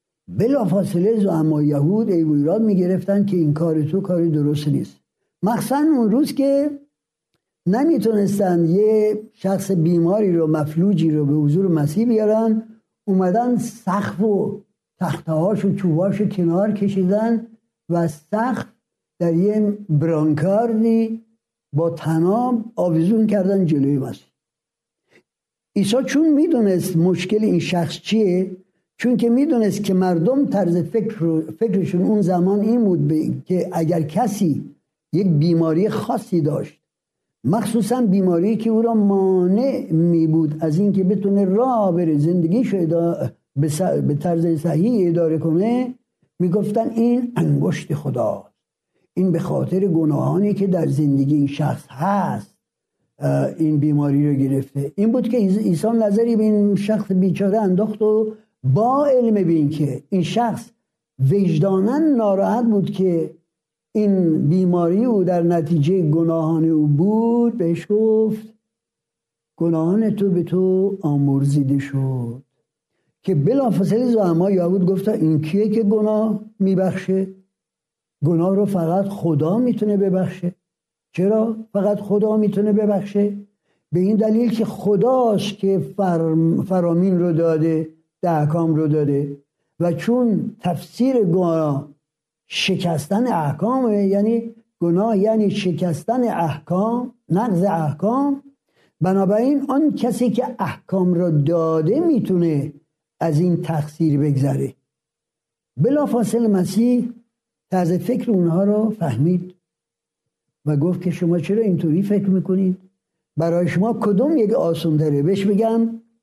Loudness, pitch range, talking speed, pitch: -19 LUFS, 165-215 Hz, 125 wpm, 190 Hz